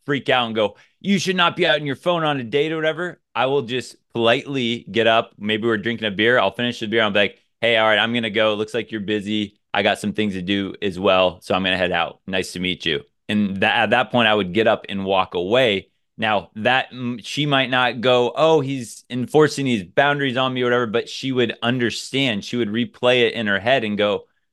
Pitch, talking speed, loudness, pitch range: 115 Hz, 250 wpm, -20 LUFS, 105-130 Hz